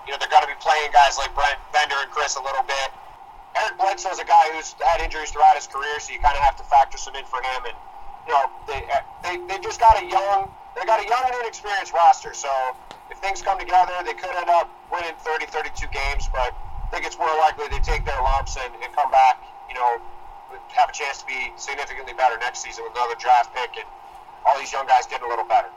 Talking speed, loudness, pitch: 245 wpm, -22 LUFS, 210 Hz